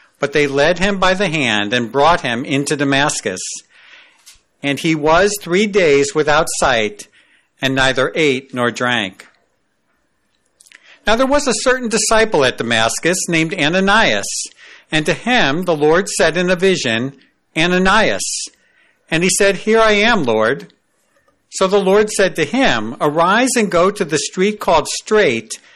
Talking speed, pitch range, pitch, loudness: 150 wpm, 140-205 Hz, 175 Hz, -15 LUFS